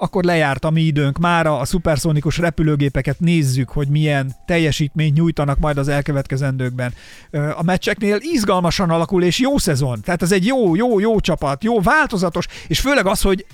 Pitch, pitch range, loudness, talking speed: 165 Hz, 145-190 Hz, -17 LUFS, 165 wpm